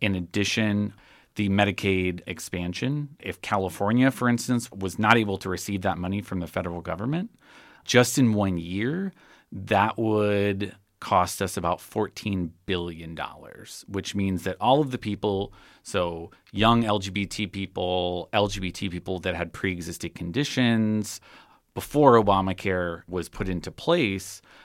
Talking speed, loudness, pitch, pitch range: 135 wpm, -26 LUFS, 100 Hz, 90-110 Hz